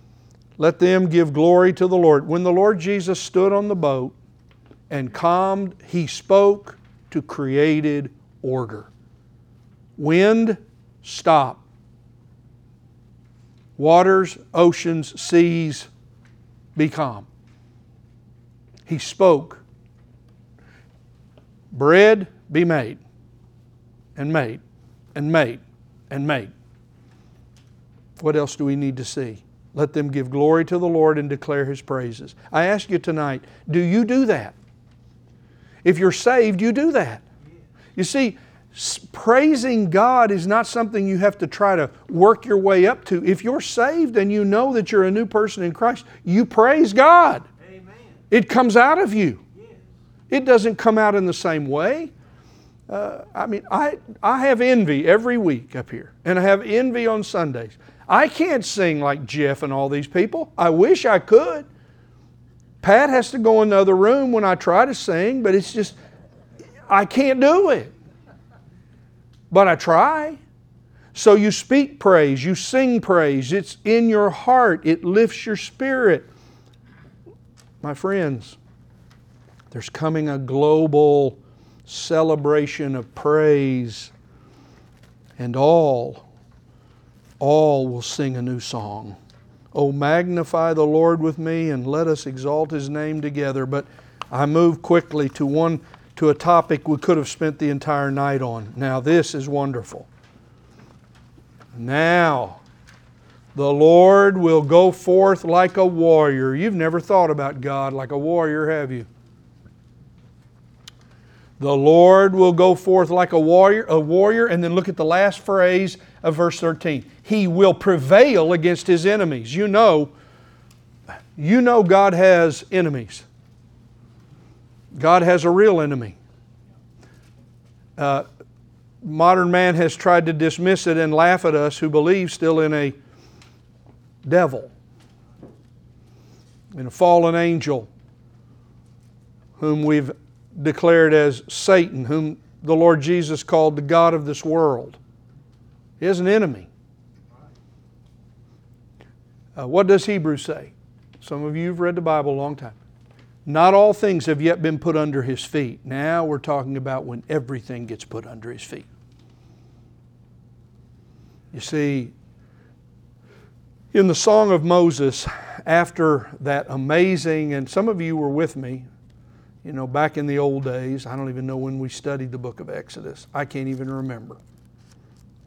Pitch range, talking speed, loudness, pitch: 130-185 Hz, 140 wpm, -18 LUFS, 155 Hz